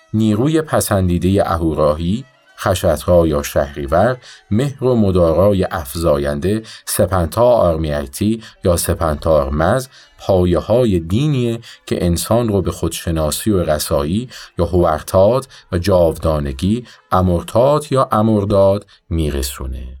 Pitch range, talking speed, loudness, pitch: 80-110 Hz, 100 wpm, -16 LUFS, 90 Hz